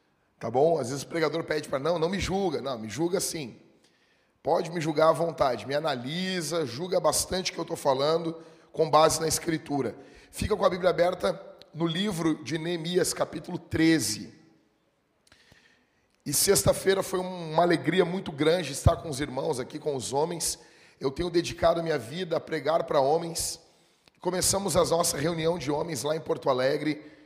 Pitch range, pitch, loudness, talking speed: 155-175 Hz, 165 Hz, -27 LUFS, 175 wpm